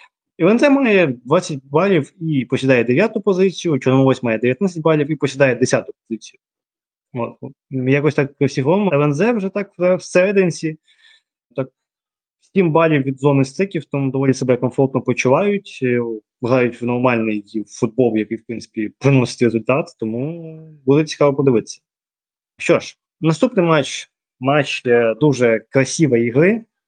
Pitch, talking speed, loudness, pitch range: 140 Hz, 130 wpm, -17 LUFS, 125-165 Hz